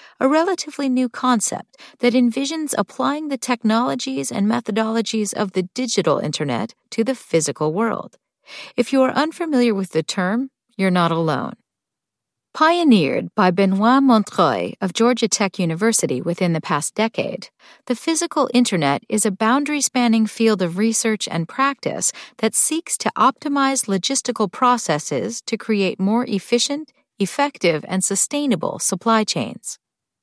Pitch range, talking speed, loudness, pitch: 195-265 Hz, 135 wpm, -19 LUFS, 225 Hz